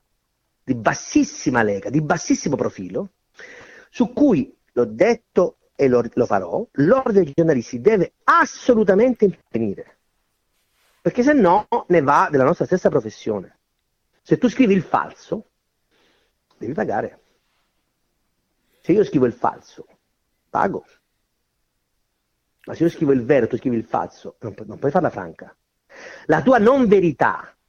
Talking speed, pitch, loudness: 135 wpm, 180 Hz, -19 LUFS